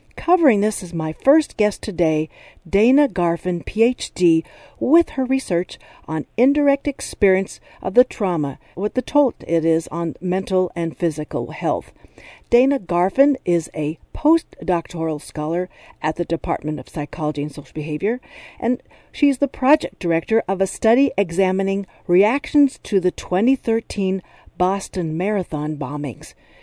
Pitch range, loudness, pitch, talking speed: 165-245 Hz, -20 LUFS, 185 Hz, 135 wpm